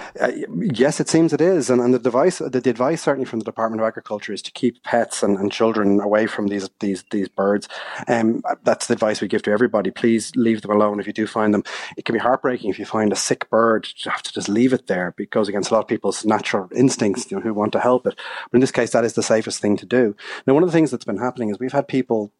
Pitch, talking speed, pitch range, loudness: 115 Hz, 285 wpm, 105-125 Hz, -20 LUFS